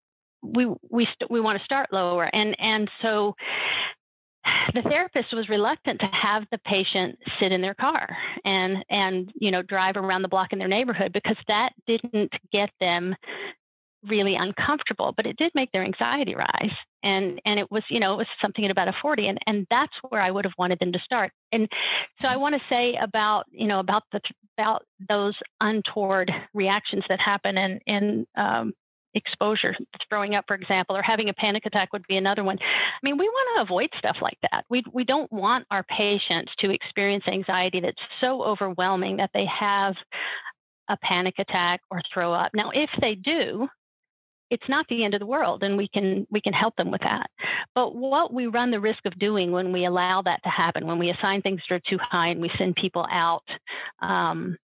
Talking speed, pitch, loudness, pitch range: 200 wpm, 205 Hz, -25 LUFS, 190-225 Hz